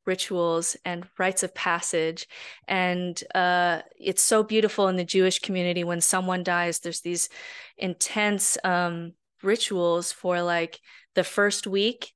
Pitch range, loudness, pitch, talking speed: 175-195 Hz, -25 LUFS, 180 Hz, 135 wpm